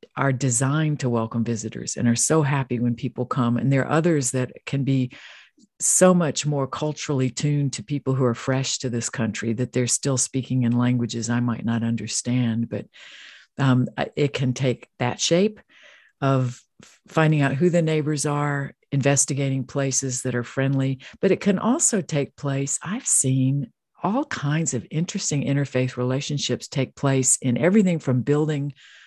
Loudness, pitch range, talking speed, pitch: -23 LUFS, 125-150 Hz, 165 wpm, 135 Hz